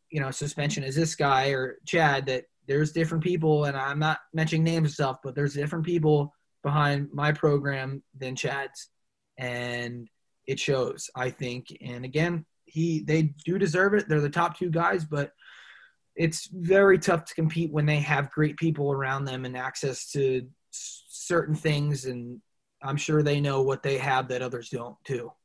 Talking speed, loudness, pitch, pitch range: 175 wpm, -27 LUFS, 145 Hz, 135-160 Hz